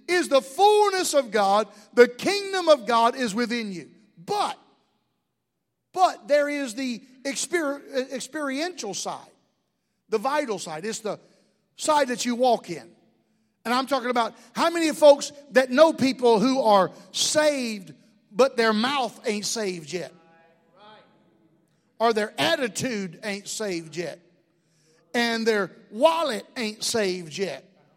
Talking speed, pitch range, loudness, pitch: 130 wpm, 195-275 Hz, -24 LUFS, 230 Hz